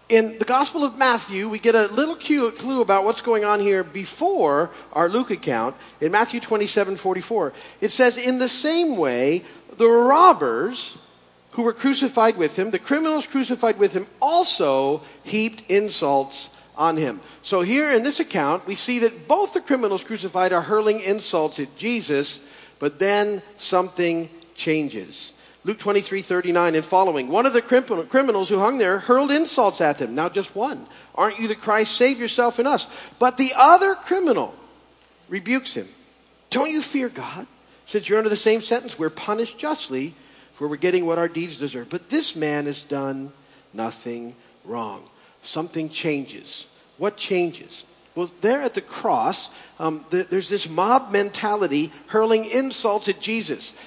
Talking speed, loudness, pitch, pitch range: 165 wpm, -21 LUFS, 210 Hz, 175-245 Hz